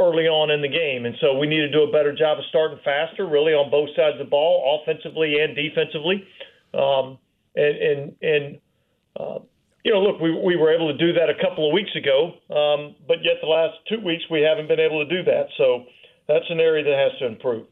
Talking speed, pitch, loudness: 235 wpm, 160 Hz, -21 LUFS